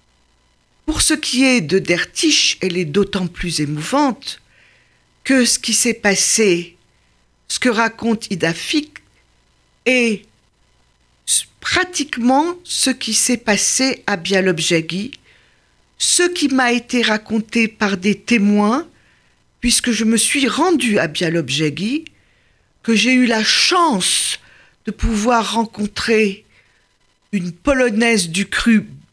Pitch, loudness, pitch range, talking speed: 225 Hz, -16 LUFS, 200-255 Hz, 115 wpm